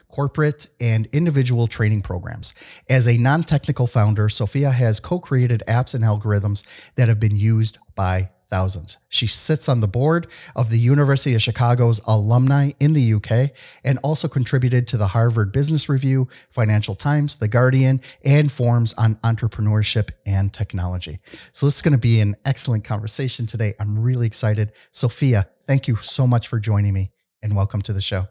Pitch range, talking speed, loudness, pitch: 105-135 Hz, 165 wpm, -19 LUFS, 115 Hz